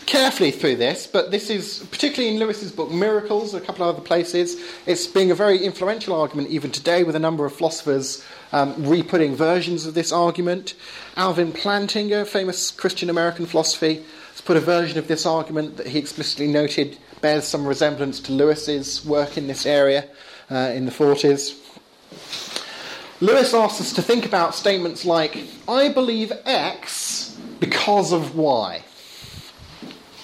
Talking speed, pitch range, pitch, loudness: 155 wpm, 150-190 Hz, 170 Hz, -21 LUFS